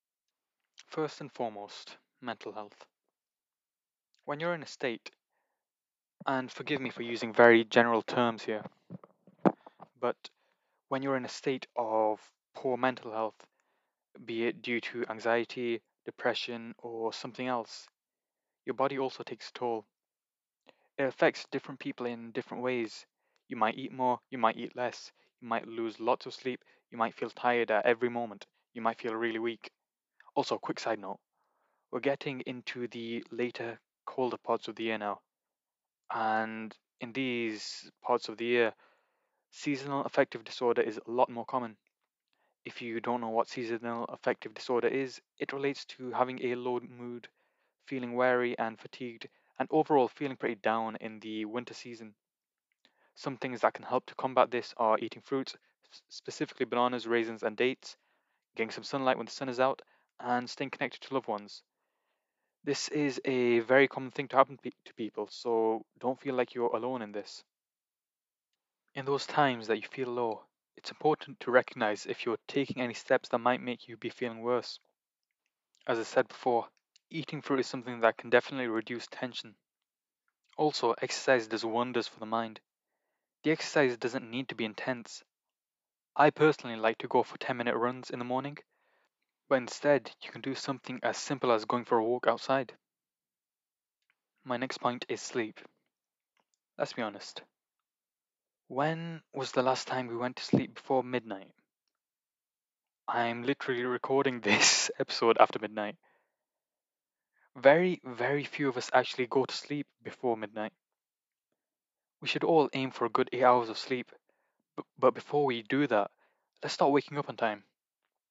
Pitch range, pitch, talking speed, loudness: 115-135 Hz, 125 Hz, 160 wpm, -32 LUFS